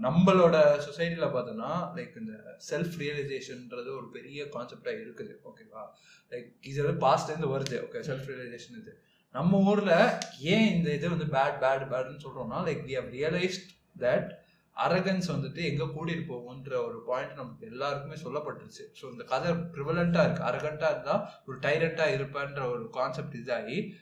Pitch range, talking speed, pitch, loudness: 140-175 Hz, 120 wpm, 155 Hz, -30 LUFS